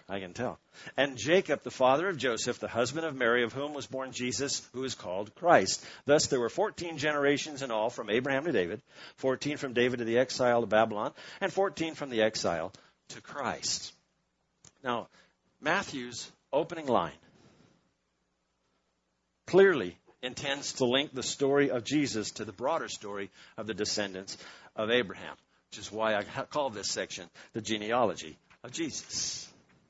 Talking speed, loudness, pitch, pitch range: 160 wpm, -31 LUFS, 125 Hz, 110-140 Hz